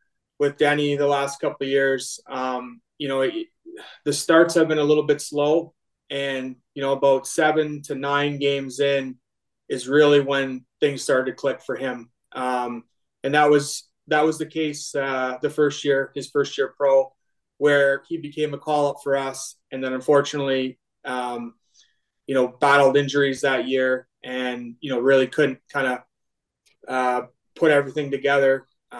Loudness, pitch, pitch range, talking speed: -22 LUFS, 140 Hz, 130-150 Hz, 170 wpm